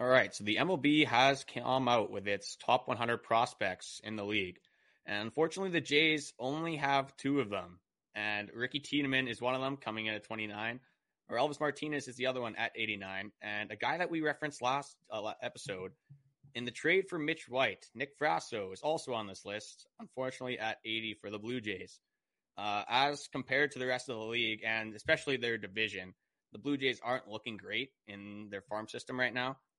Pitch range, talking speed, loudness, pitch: 105-140 Hz, 195 wpm, -35 LUFS, 125 Hz